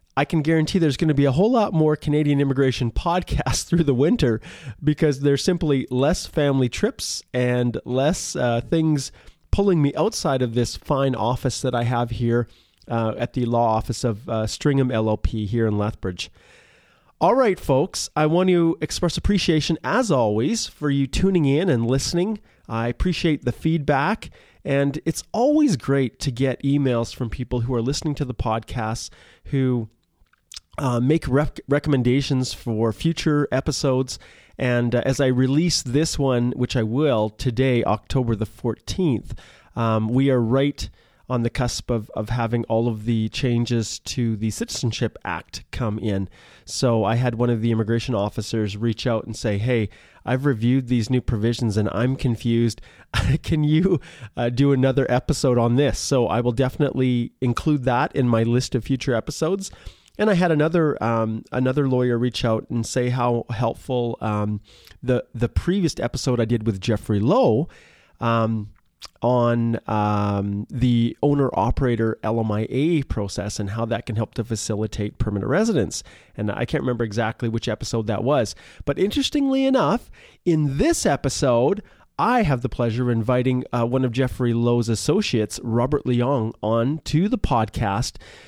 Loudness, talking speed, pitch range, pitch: -22 LUFS, 165 wpm, 115-140 Hz, 125 Hz